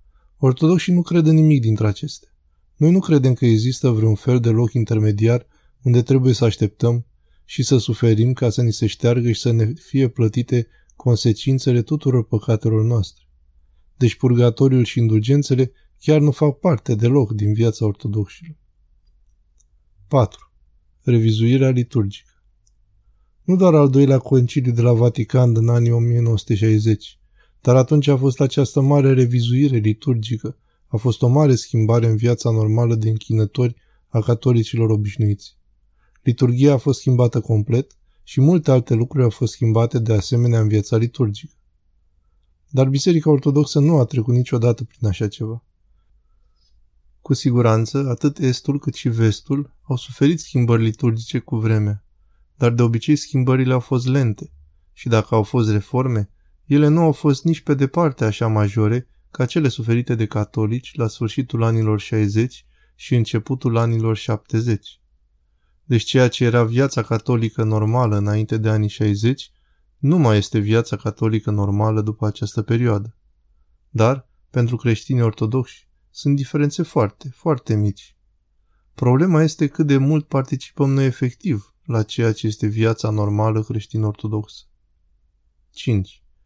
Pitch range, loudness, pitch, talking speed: 105-130 Hz, -18 LUFS, 115 Hz, 140 wpm